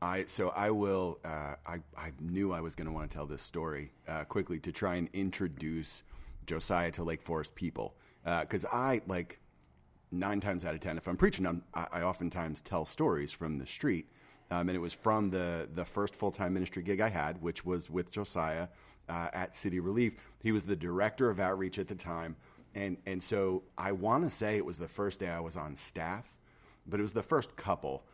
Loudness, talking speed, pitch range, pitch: -35 LUFS, 215 wpm, 80-100 Hz, 90 Hz